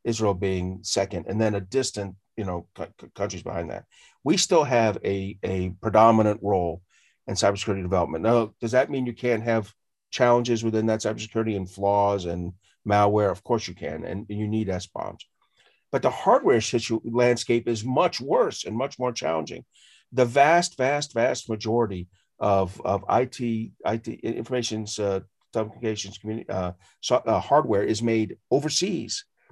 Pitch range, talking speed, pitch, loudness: 100-120 Hz, 160 wpm, 110 Hz, -25 LUFS